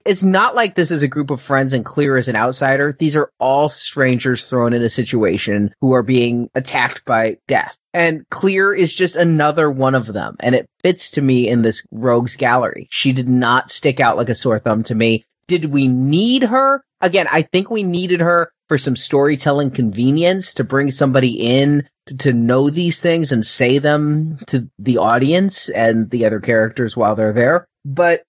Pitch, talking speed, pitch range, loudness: 135 Hz, 195 wpm, 120-170 Hz, -16 LUFS